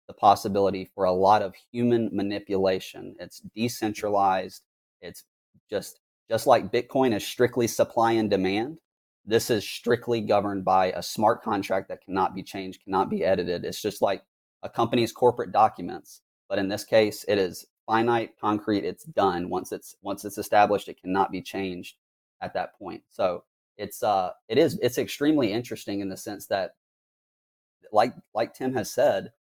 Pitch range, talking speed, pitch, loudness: 95-115 Hz, 165 wpm, 105 Hz, -26 LUFS